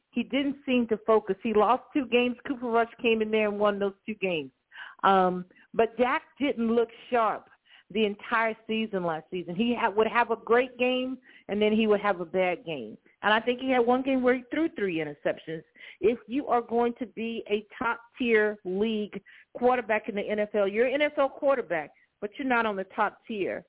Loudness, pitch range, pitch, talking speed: -27 LUFS, 205-245 Hz, 225 Hz, 205 wpm